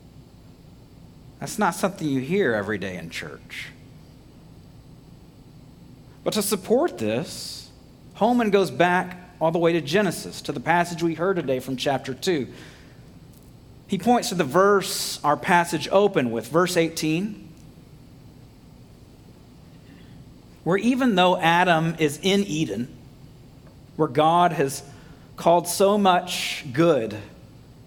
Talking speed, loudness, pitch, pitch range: 120 wpm, -22 LUFS, 170 Hz, 150-195 Hz